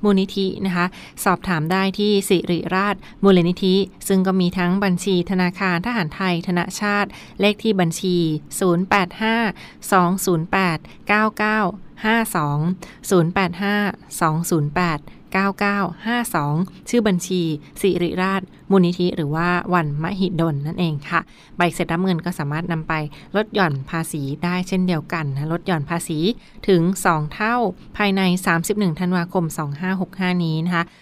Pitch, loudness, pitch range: 180 Hz, -20 LUFS, 170-195 Hz